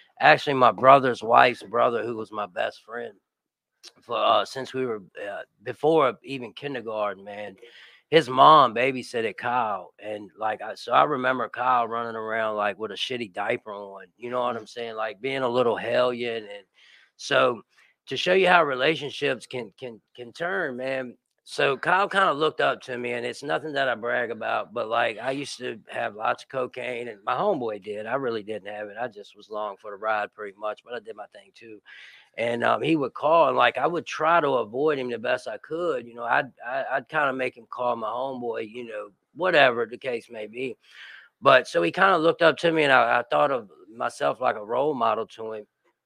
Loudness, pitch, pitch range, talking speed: -24 LUFS, 120 Hz, 105-130 Hz, 220 wpm